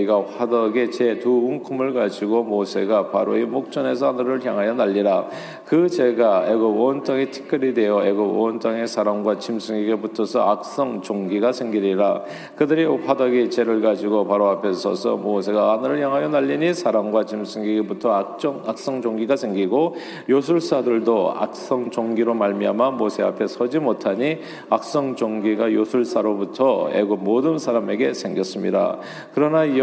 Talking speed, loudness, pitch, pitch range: 335 characters per minute, -21 LUFS, 115 Hz, 105-130 Hz